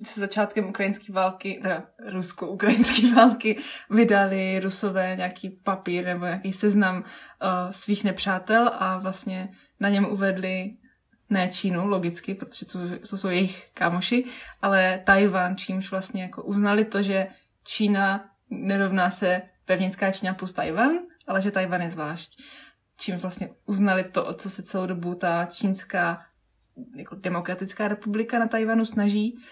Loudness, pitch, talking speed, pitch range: -25 LUFS, 195 Hz, 140 wpm, 185-210 Hz